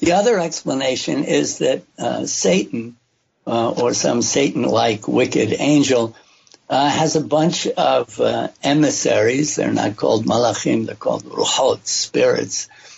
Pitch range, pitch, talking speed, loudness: 120-160 Hz, 140 Hz, 135 wpm, -18 LUFS